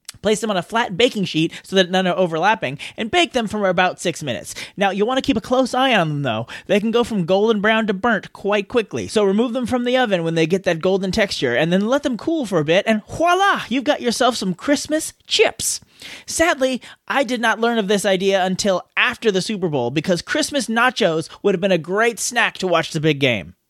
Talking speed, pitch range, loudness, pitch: 240 wpm, 185-245 Hz, -19 LUFS, 210 Hz